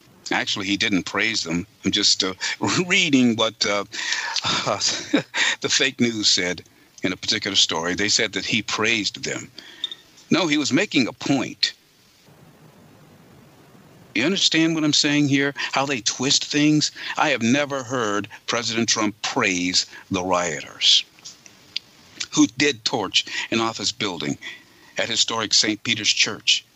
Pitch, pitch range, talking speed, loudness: 120 Hz, 105-145 Hz, 140 wpm, -20 LUFS